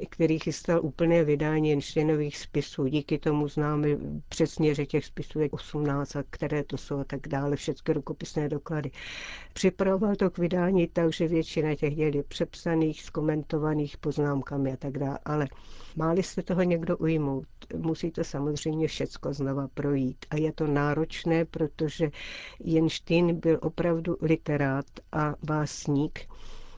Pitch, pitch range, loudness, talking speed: 155 Hz, 145-165 Hz, -29 LUFS, 140 wpm